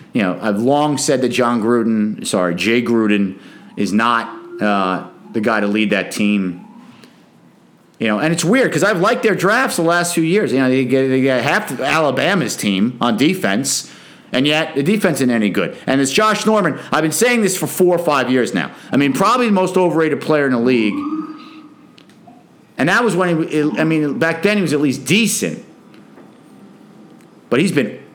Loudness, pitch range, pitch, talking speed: -16 LUFS, 115-185 Hz, 145 Hz, 200 wpm